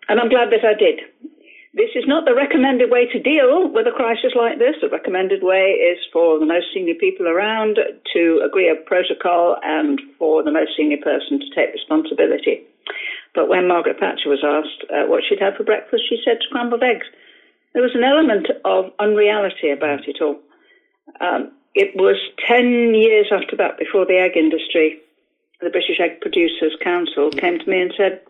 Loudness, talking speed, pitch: -17 LUFS, 185 wpm, 245 Hz